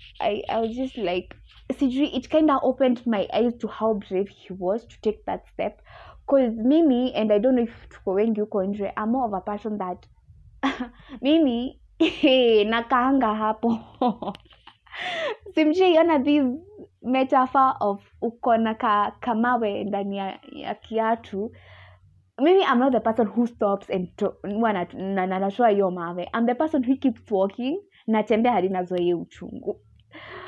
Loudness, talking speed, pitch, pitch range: -23 LUFS, 130 wpm, 230 Hz, 200-265 Hz